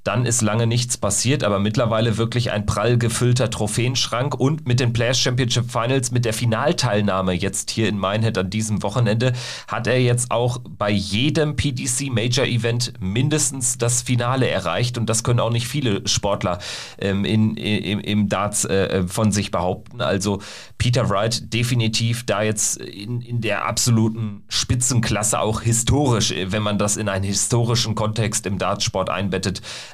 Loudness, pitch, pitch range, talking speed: -20 LUFS, 115 Hz, 105-125 Hz, 160 wpm